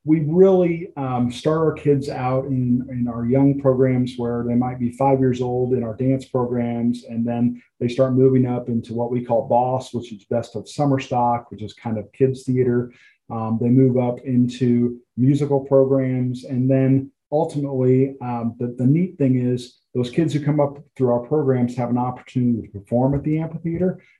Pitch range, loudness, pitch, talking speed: 120-135 Hz, -20 LUFS, 125 Hz, 195 wpm